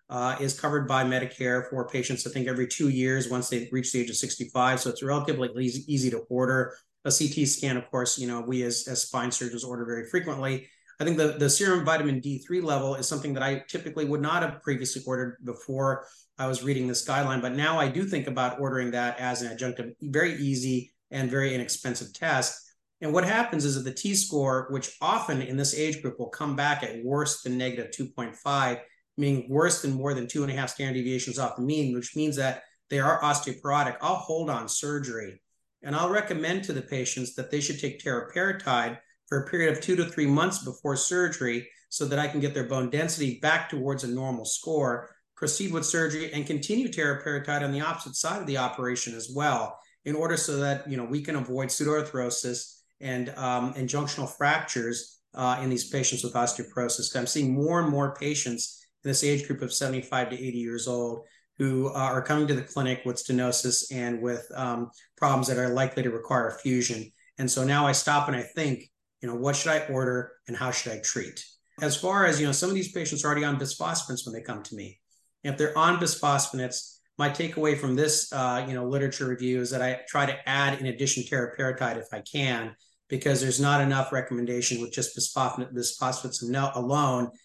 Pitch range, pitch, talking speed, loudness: 125-145 Hz, 135 Hz, 210 wpm, -28 LUFS